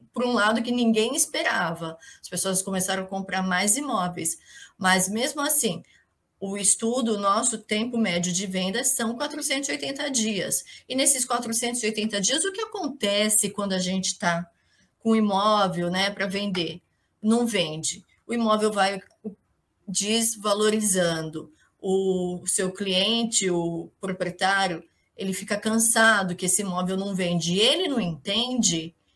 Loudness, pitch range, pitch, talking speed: -24 LUFS, 185-230 Hz, 200 Hz, 135 wpm